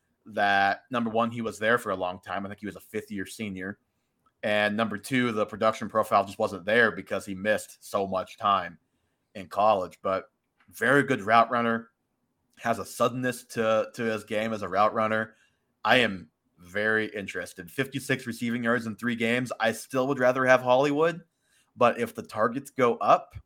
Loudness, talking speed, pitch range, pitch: -27 LUFS, 185 wpm, 105-125 Hz, 115 Hz